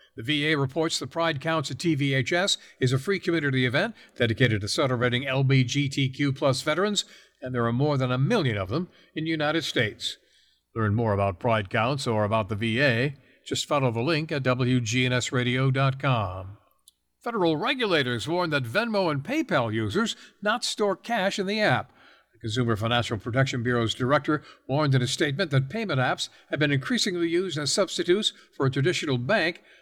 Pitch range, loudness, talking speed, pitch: 125-165 Hz, -25 LUFS, 165 wpm, 135 Hz